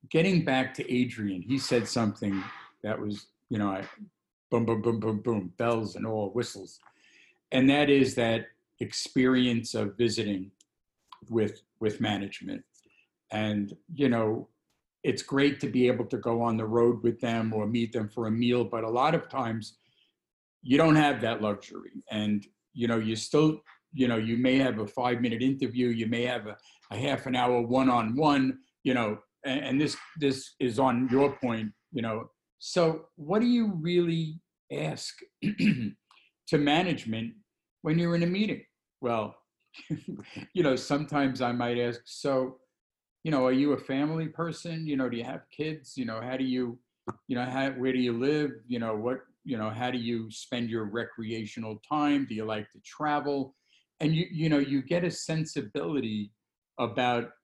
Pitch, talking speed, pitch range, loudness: 125 Hz, 175 wpm, 115-140 Hz, -29 LUFS